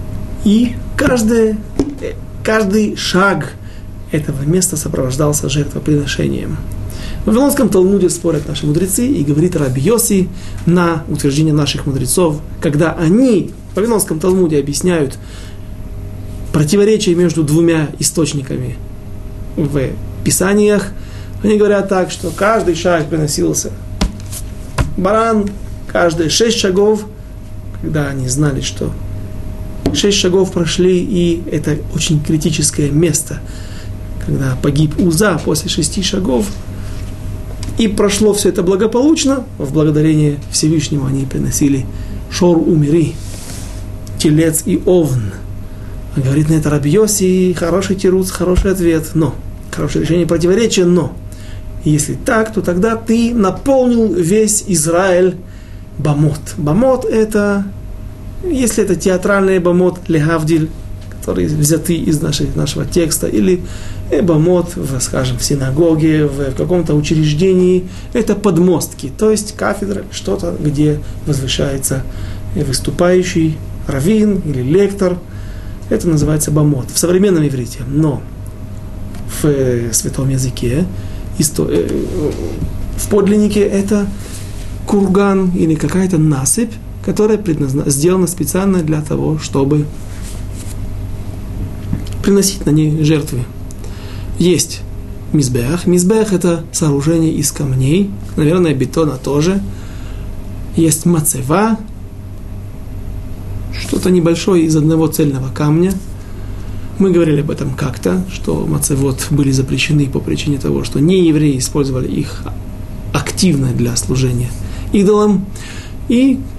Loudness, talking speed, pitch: -14 LUFS, 105 wpm, 150 Hz